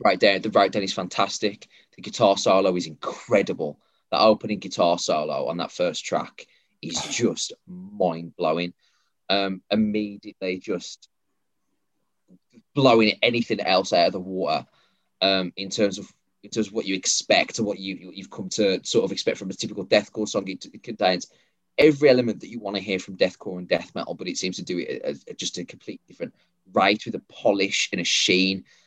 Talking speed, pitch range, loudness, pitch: 190 wpm, 95-115 Hz, -23 LUFS, 100 Hz